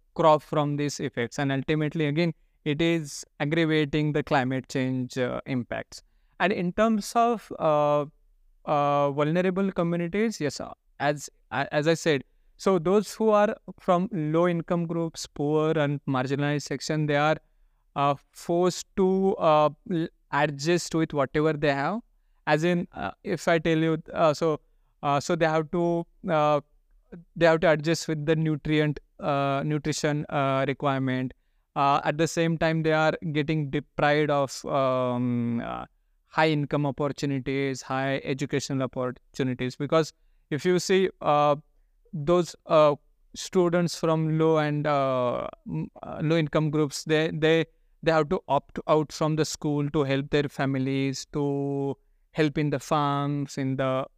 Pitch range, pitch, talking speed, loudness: 140-165 Hz, 150 Hz, 145 wpm, -26 LUFS